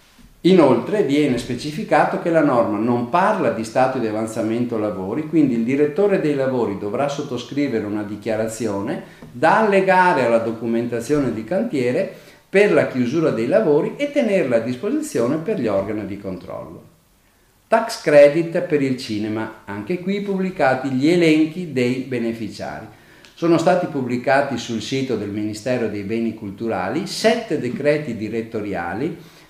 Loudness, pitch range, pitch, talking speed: -19 LUFS, 110-165 Hz, 130 Hz, 135 wpm